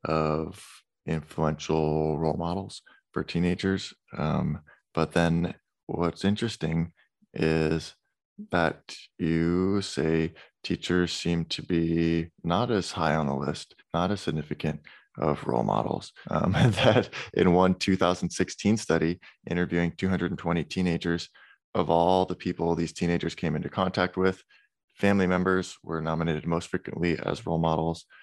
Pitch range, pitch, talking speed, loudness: 80-90 Hz, 85 Hz, 130 wpm, -27 LUFS